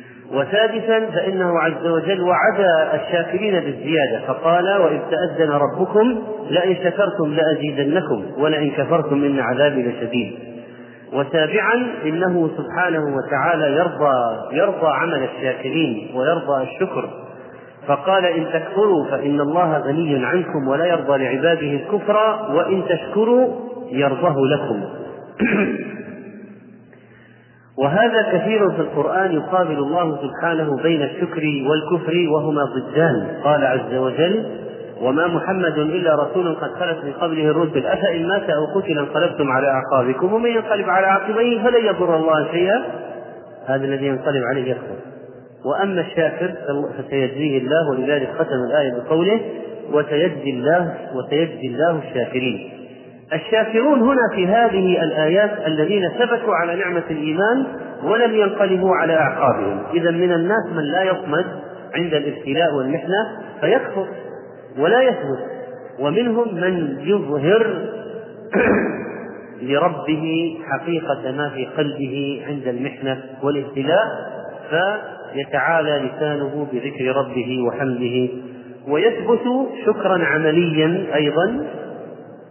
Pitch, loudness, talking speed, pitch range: 160 Hz, -19 LUFS, 105 wpm, 140-190 Hz